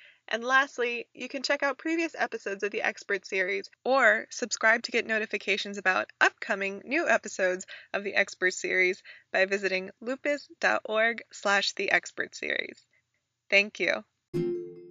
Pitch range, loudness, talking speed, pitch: 195-255 Hz, -28 LUFS, 135 wpm, 215 Hz